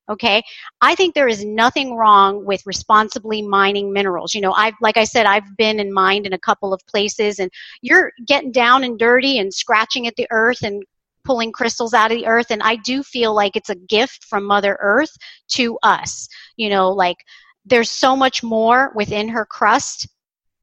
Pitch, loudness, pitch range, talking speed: 220 Hz, -16 LUFS, 200-240 Hz, 195 wpm